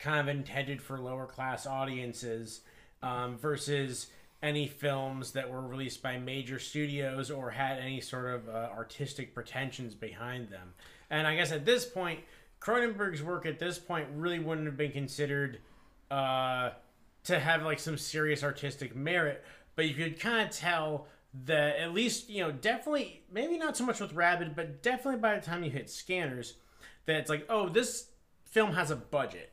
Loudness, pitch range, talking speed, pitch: -34 LUFS, 130-175 Hz, 175 wpm, 145 Hz